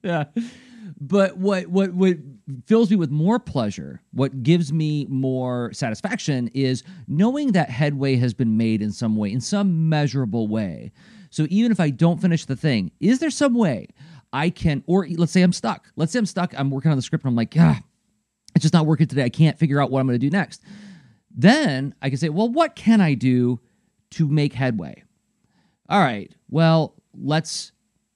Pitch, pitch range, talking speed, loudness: 160 Hz, 135-190 Hz, 195 wpm, -21 LUFS